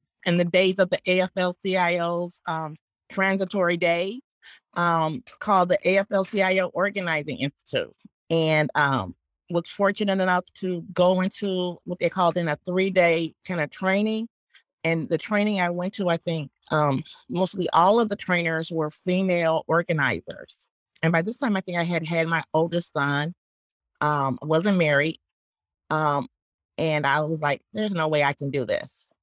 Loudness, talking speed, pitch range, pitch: -24 LUFS, 155 wpm, 155-185 Hz, 175 Hz